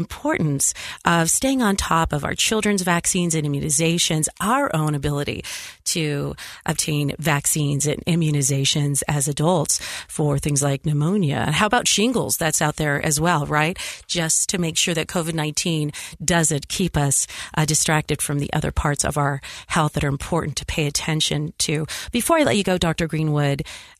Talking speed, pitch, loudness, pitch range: 165 wpm, 155 Hz, -21 LUFS, 145-170 Hz